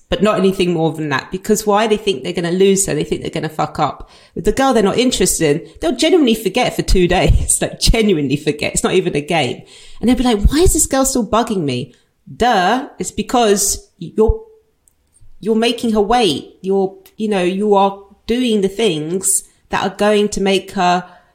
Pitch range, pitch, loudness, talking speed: 180-220 Hz, 195 Hz, -16 LUFS, 215 wpm